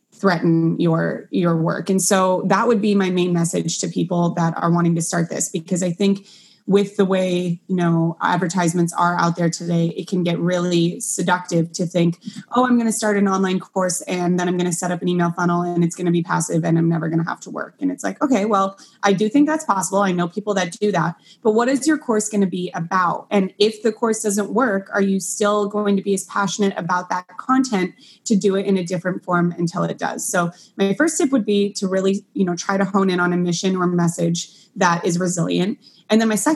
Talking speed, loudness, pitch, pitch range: 240 wpm, -20 LUFS, 185 Hz, 175-205 Hz